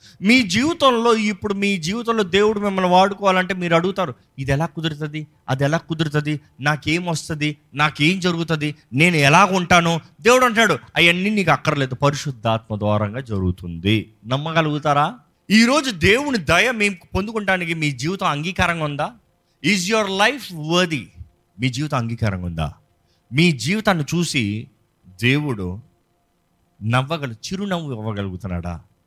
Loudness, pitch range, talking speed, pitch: -19 LUFS, 130-190 Hz, 115 wpm, 155 Hz